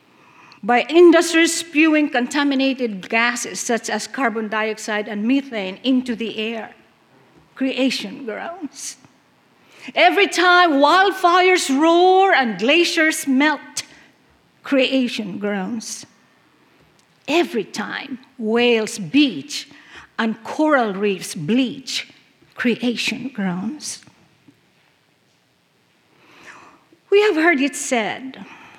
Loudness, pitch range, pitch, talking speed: -18 LUFS, 225-305 Hz, 260 Hz, 85 wpm